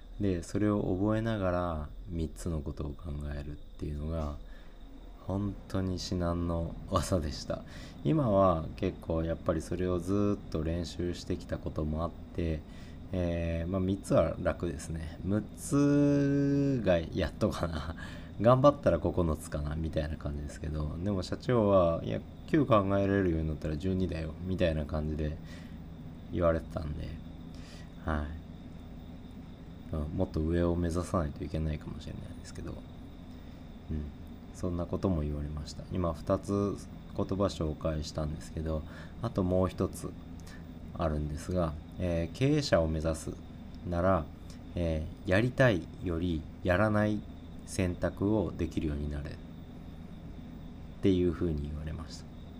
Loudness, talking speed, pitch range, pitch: -32 LUFS, 265 characters per minute, 80-90 Hz, 85 Hz